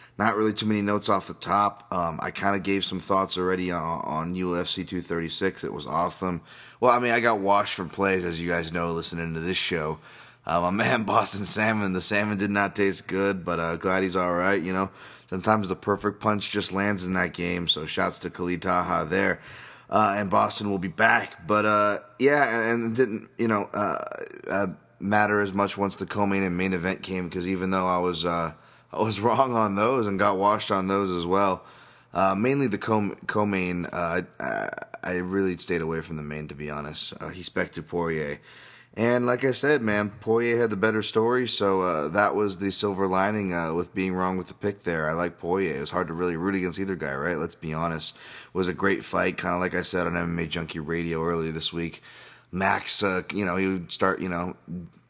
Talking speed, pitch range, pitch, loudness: 220 wpm, 85-105 Hz, 95 Hz, -25 LUFS